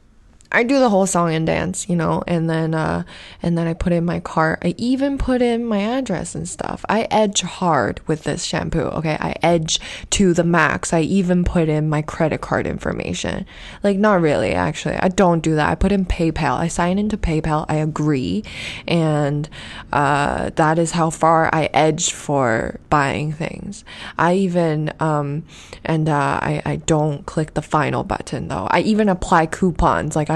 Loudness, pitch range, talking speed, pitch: -19 LUFS, 155-185 Hz, 190 wpm, 165 Hz